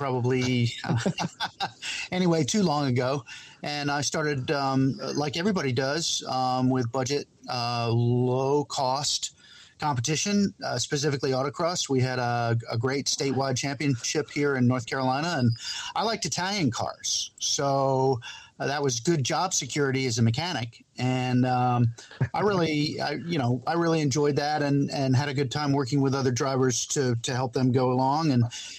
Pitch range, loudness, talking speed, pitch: 125-150 Hz, -26 LUFS, 160 wpm, 135 Hz